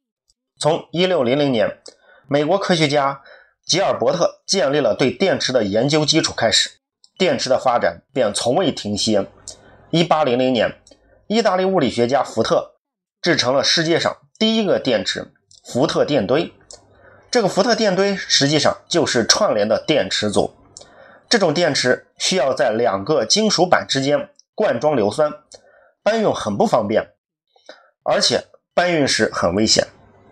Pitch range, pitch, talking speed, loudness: 125-190 Hz, 150 Hz, 230 characters per minute, -18 LUFS